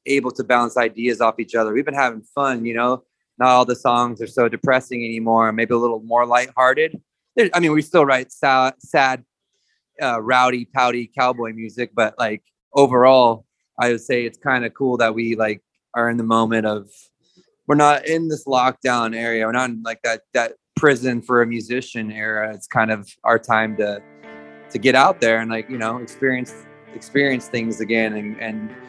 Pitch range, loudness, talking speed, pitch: 115-130 Hz, -19 LUFS, 195 wpm, 120 Hz